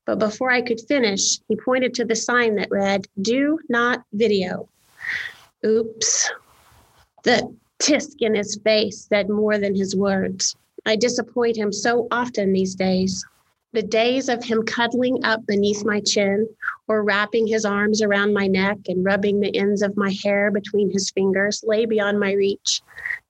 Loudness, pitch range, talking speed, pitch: -21 LUFS, 200-235 Hz, 160 wpm, 215 Hz